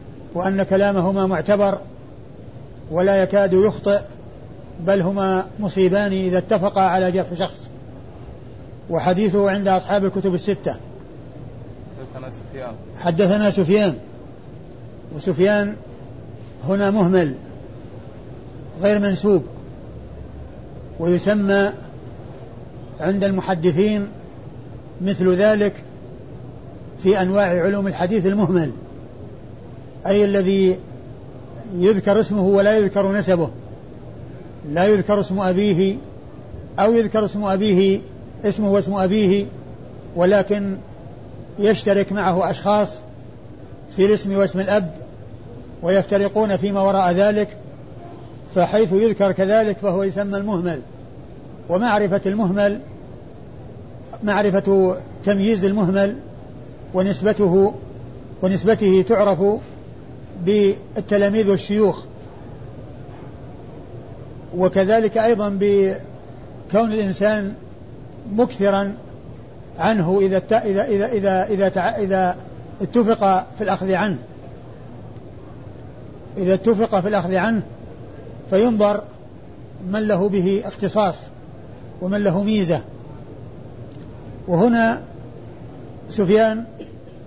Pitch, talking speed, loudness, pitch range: 190 Hz, 75 wpm, -19 LUFS, 130-200 Hz